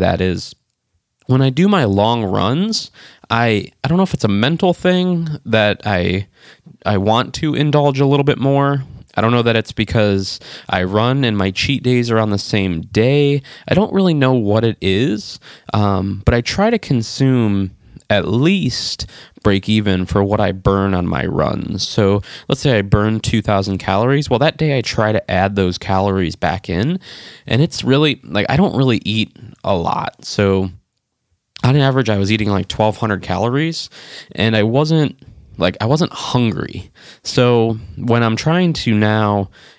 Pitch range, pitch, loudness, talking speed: 100-135 Hz, 110 Hz, -16 LUFS, 180 wpm